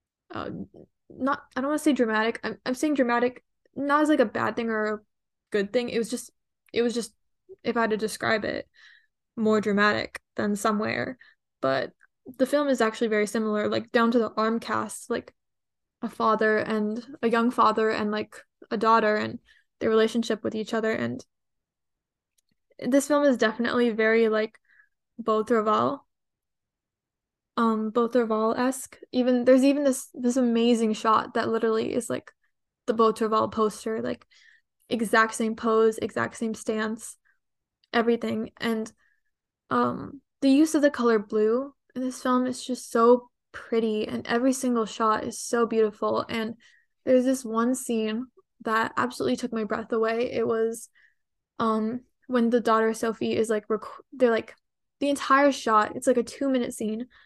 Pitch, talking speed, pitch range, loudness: 230 Hz, 160 wpm, 220-250 Hz, -25 LUFS